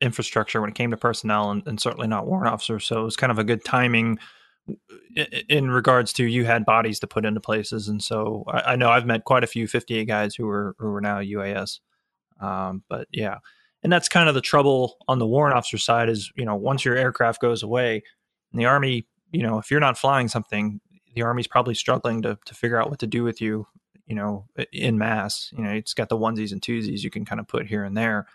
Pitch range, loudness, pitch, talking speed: 110-125 Hz, -23 LUFS, 115 Hz, 240 wpm